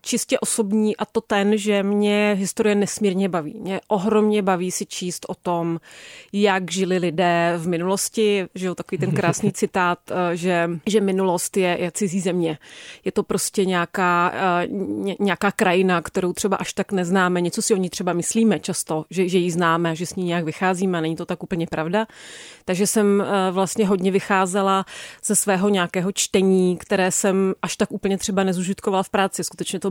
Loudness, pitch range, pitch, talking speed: -21 LUFS, 180-205 Hz, 190 Hz, 175 wpm